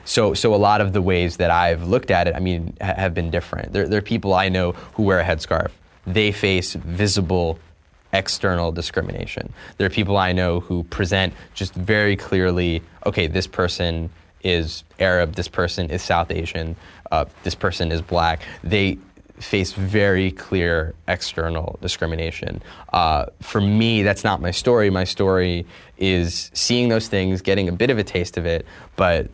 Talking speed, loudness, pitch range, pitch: 175 wpm, -21 LUFS, 85-100 Hz, 90 Hz